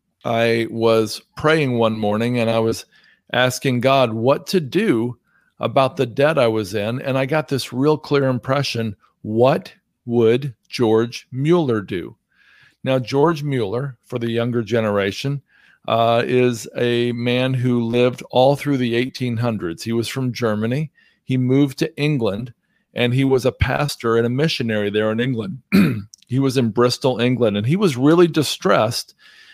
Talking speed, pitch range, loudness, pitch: 155 wpm, 115-135 Hz, -19 LUFS, 125 Hz